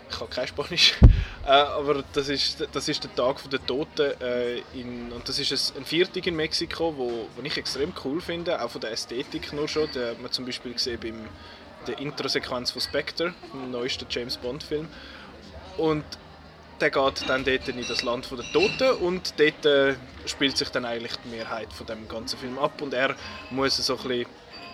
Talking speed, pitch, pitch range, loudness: 185 wpm, 130 Hz, 120-150 Hz, -26 LUFS